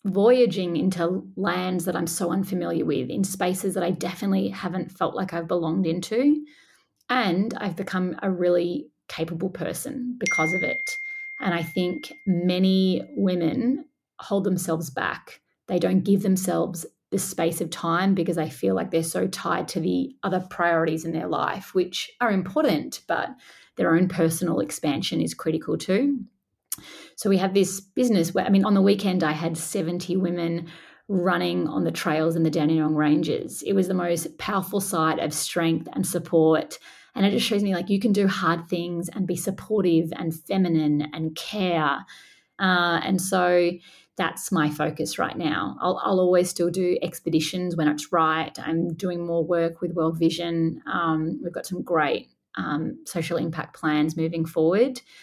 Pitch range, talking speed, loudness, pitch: 165-195 Hz, 170 wpm, -24 LUFS, 175 Hz